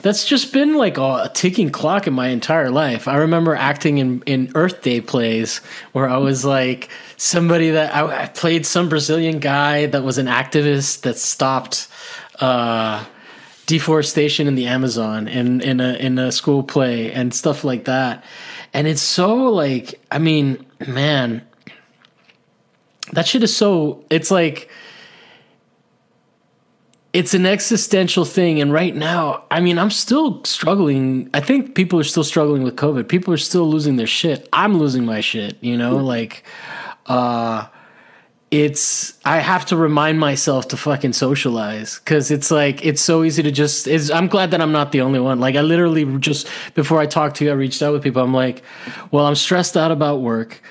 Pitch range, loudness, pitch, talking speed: 130-165 Hz, -17 LUFS, 150 Hz, 175 wpm